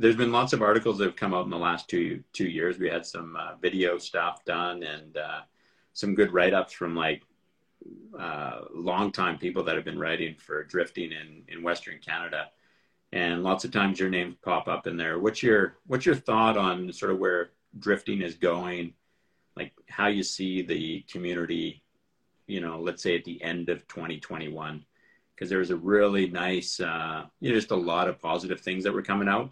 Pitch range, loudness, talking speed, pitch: 85-100 Hz, -28 LUFS, 200 wpm, 90 Hz